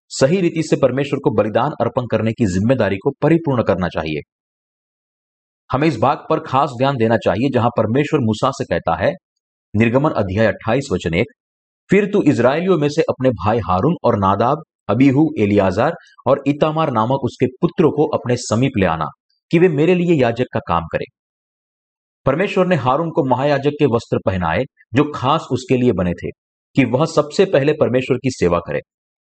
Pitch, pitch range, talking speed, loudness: 130 Hz, 110-150 Hz, 175 wpm, -17 LUFS